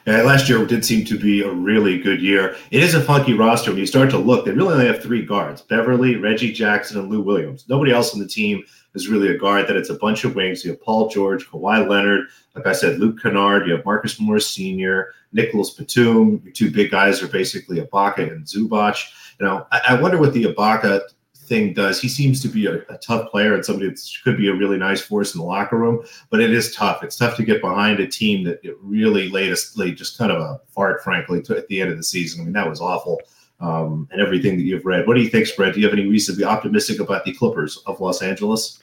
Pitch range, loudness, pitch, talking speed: 95-120 Hz, -18 LUFS, 105 Hz, 250 wpm